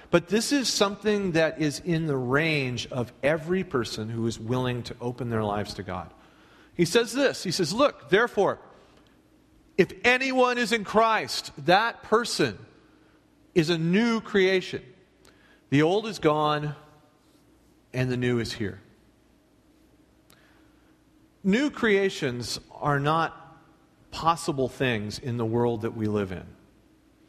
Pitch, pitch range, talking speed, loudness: 150 Hz, 120-190 Hz, 135 wpm, -26 LUFS